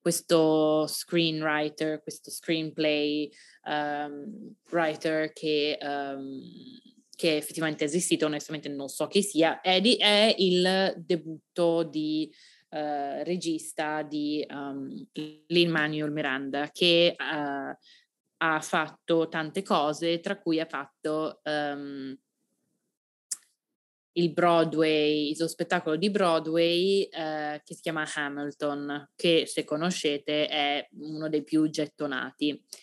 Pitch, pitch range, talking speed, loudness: 155 Hz, 150-170 Hz, 115 wpm, -27 LUFS